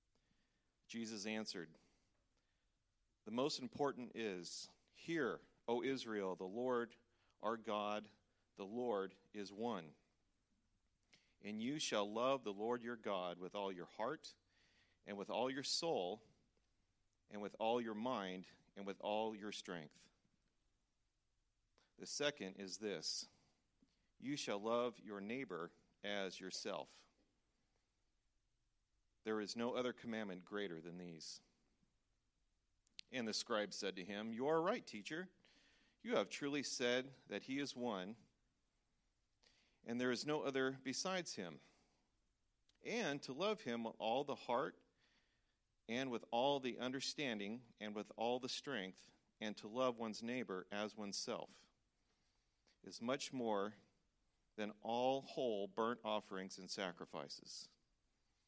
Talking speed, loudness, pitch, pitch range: 125 wpm, -45 LUFS, 110 Hz, 100-125 Hz